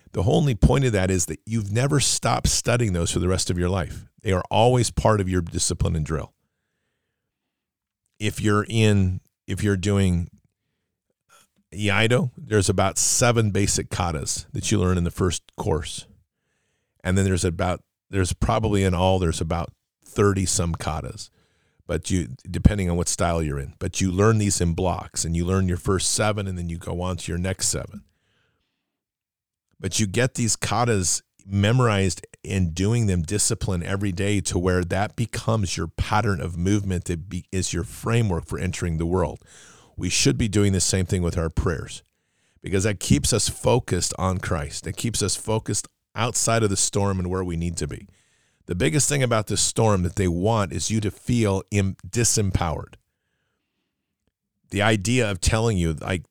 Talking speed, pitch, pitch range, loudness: 180 wpm, 95 Hz, 90-110 Hz, -23 LUFS